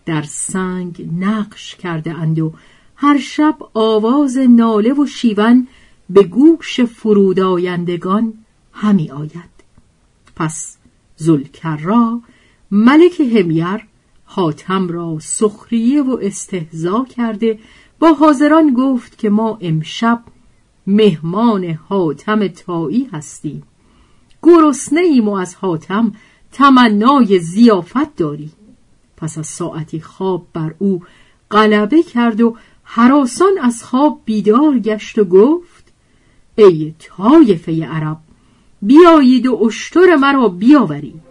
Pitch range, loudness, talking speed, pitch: 175-250 Hz, -13 LUFS, 100 wpm, 215 Hz